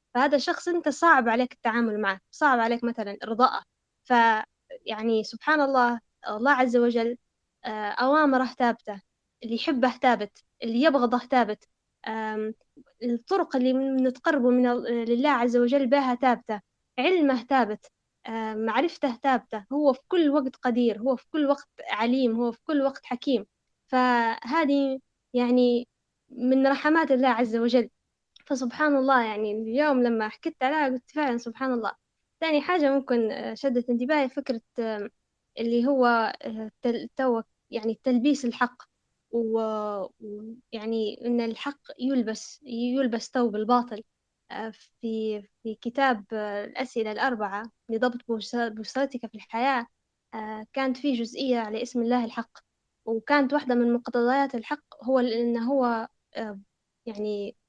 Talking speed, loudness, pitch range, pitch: 120 wpm, -26 LUFS, 225-270 Hz, 245 Hz